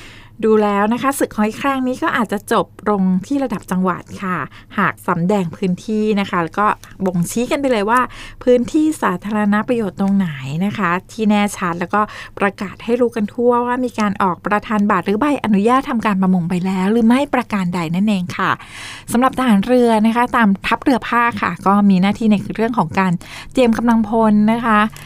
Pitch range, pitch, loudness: 195-240 Hz, 215 Hz, -17 LUFS